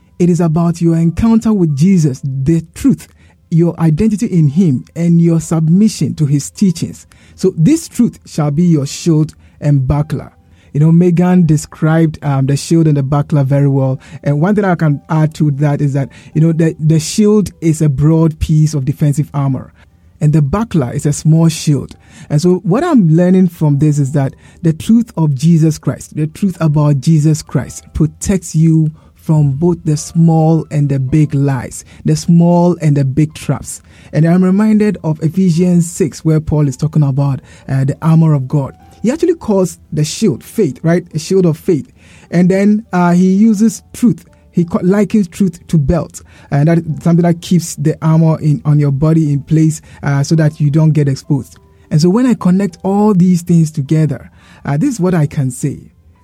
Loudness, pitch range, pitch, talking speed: -13 LUFS, 145-175 Hz, 160 Hz, 190 wpm